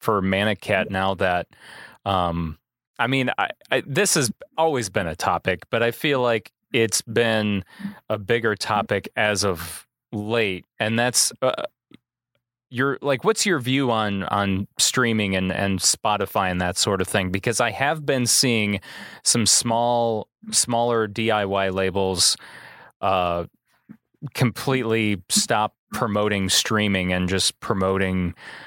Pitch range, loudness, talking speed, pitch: 95-120 Hz, -22 LUFS, 135 wpm, 110 Hz